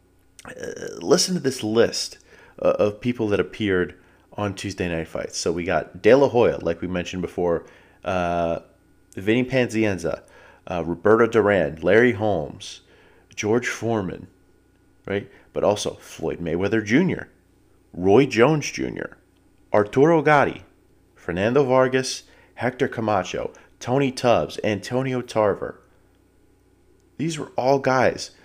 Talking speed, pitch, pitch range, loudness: 120 wpm, 105 Hz, 90-130 Hz, -22 LUFS